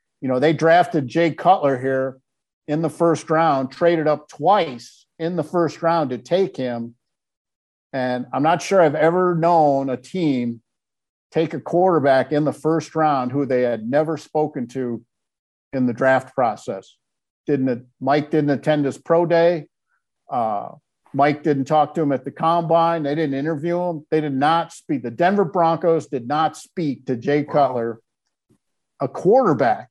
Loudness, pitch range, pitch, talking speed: -20 LUFS, 130-165 Hz, 150 Hz, 165 wpm